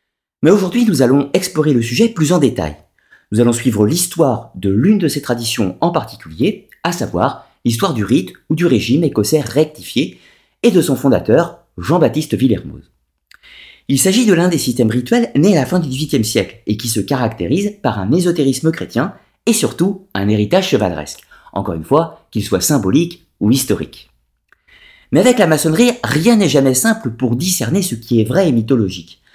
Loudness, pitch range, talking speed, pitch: -15 LUFS, 115-180 Hz, 180 wpm, 140 Hz